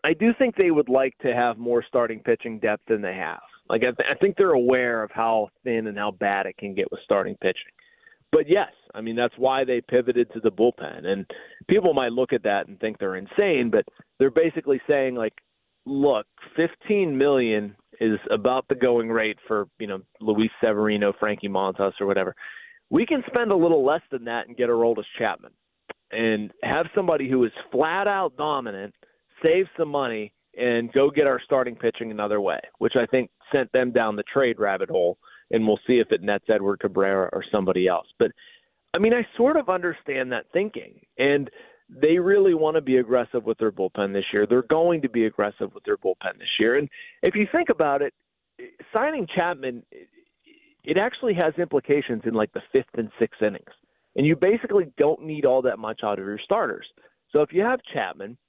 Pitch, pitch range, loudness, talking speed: 130 Hz, 110-185 Hz, -23 LUFS, 205 wpm